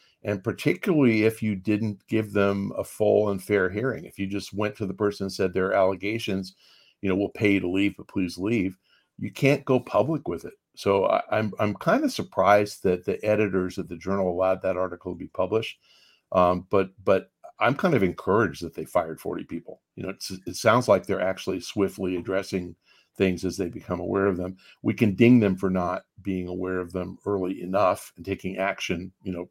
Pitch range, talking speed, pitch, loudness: 95-105 Hz, 210 wpm, 95 Hz, -25 LUFS